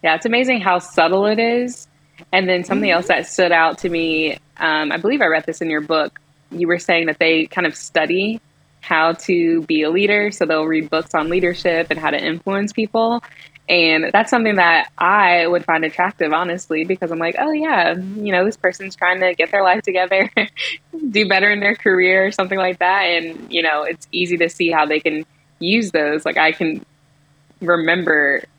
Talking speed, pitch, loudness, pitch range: 205 wpm, 175 Hz, -17 LUFS, 160-195 Hz